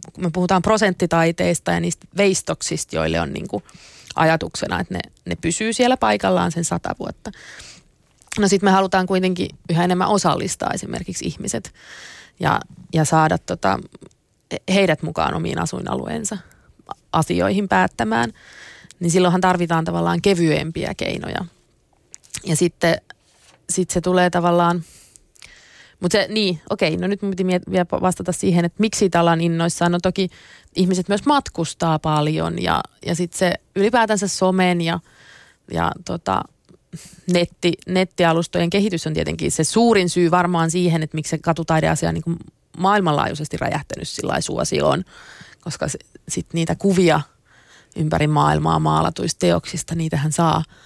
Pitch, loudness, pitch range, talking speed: 175 Hz, -20 LUFS, 160-185 Hz, 135 wpm